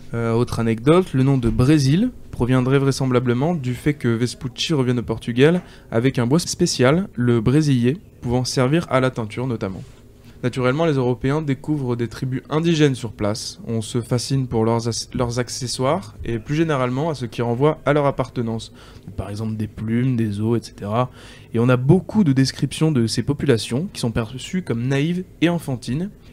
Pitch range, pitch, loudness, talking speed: 120-140 Hz, 125 Hz, -20 LUFS, 175 wpm